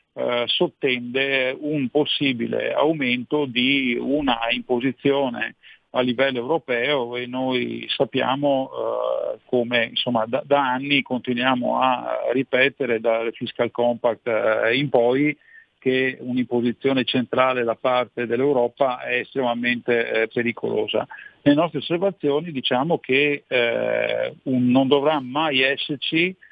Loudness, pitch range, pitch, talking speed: -22 LUFS, 120-140 Hz, 130 Hz, 115 wpm